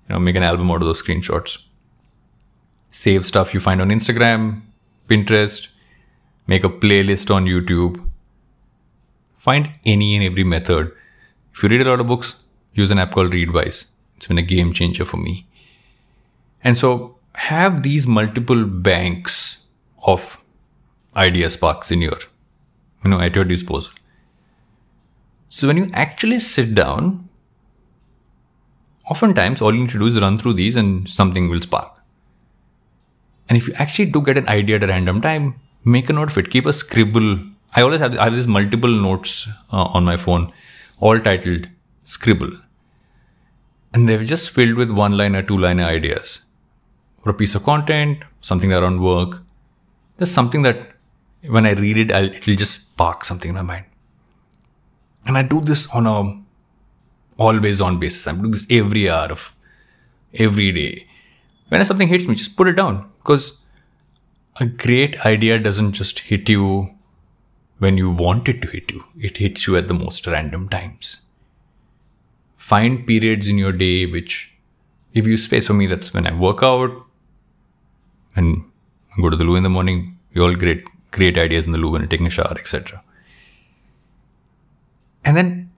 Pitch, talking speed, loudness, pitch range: 105 Hz, 165 wpm, -17 LUFS, 90-120 Hz